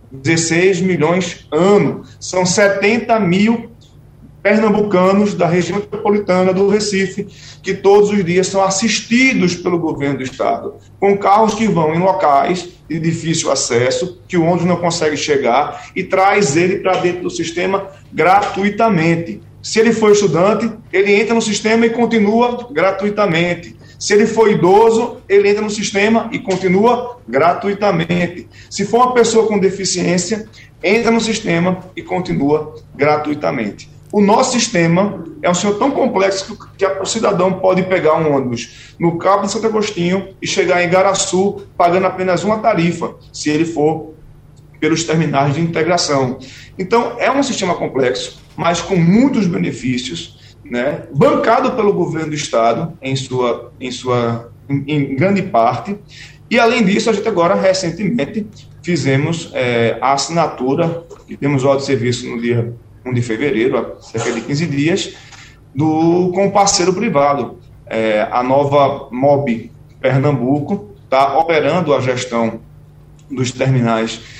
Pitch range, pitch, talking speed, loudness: 140-200 Hz, 175 Hz, 145 wpm, -15 LUFS